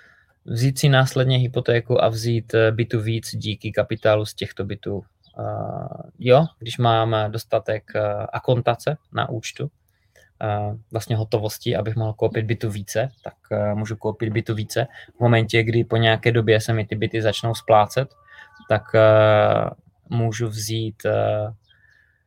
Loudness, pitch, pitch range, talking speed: -21 LUFS, 115 Hz, 110-120 Hz, 125 wpm